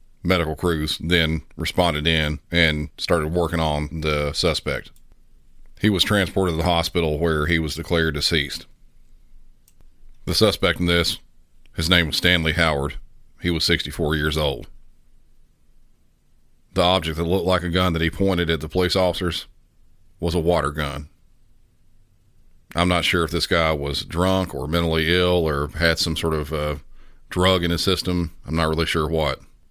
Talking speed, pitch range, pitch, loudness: 160 wpm, 80-90 Hz, 85 Hz, -21 LUFS